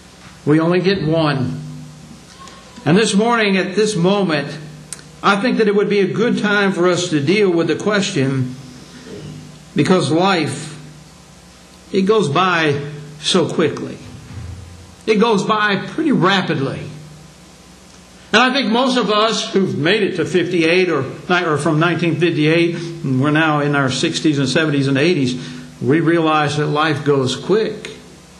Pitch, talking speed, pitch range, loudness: 165 Hz, 145 wpm, 145-195 Hz, -16 LUFS